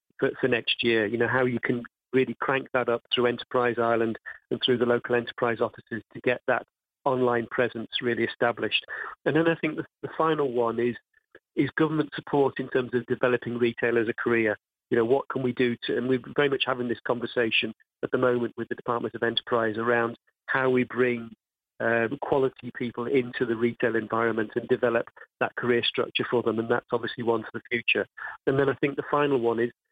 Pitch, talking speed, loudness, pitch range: 120 Hz, 205 wpm, -26 LUFS, 115-130 Hz